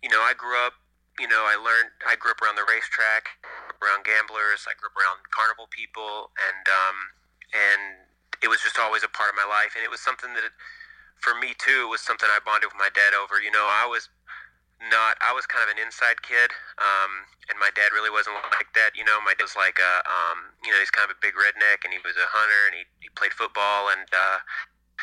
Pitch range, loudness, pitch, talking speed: 100-115 Hz, -22 LUFS, 105 Hz, 240 wpm